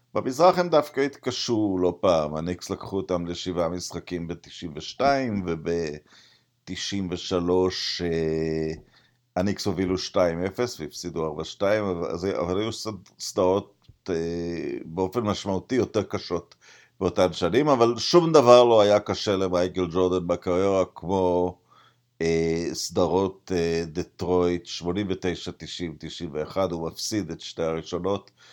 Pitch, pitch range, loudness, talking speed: 90 Hz, 85-100 Hz, -25 LUFS, 110 wpm